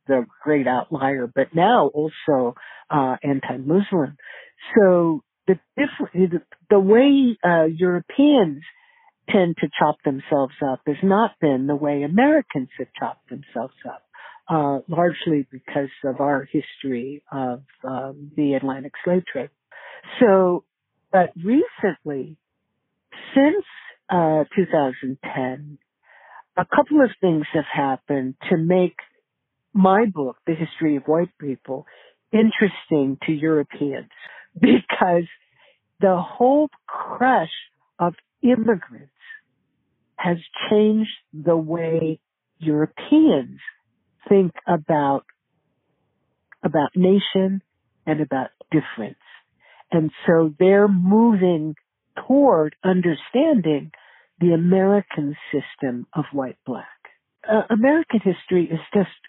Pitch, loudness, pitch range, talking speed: 165 Hz, -20 LUFS, 145-200 Hz, 100 wpm